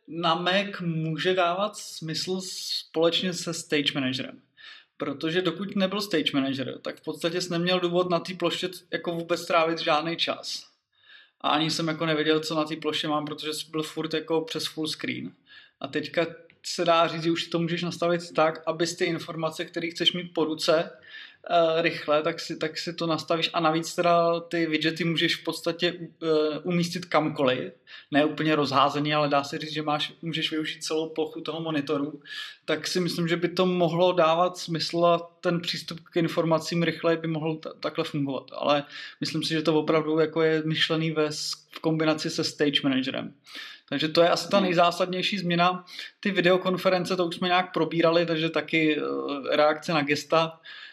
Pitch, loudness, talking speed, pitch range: 165 Hz, -26 LUFS, 180 wpm, 155-175 Hz